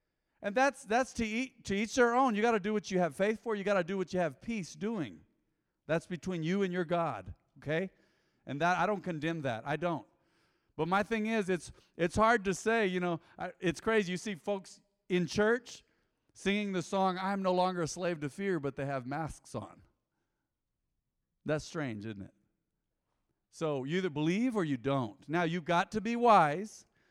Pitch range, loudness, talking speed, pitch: 160-210 Hz, -33 LUFS, 200 wpm, 185 Hz